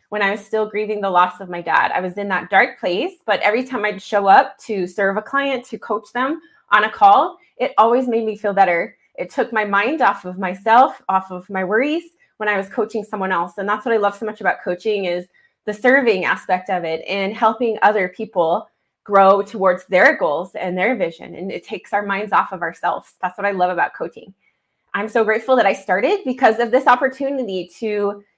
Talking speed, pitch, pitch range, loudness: 225 wpm, 210 Hz, 195-235 Hz, -18 LUFS